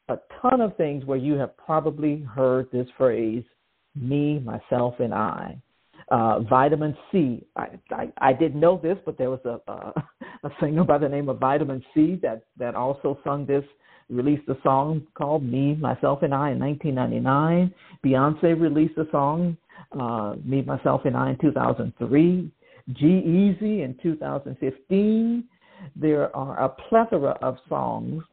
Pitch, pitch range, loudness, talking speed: 145 Hz, 130-160 Hz, -24 LUFS, 155 wpm